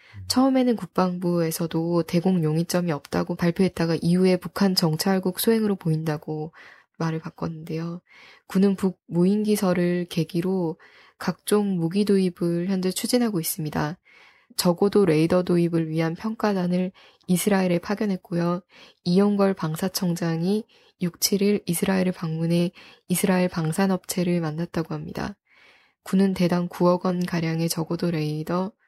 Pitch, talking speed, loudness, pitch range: 180 Hz, 310 characters per minute, -24 LUFS, 165-195 Hz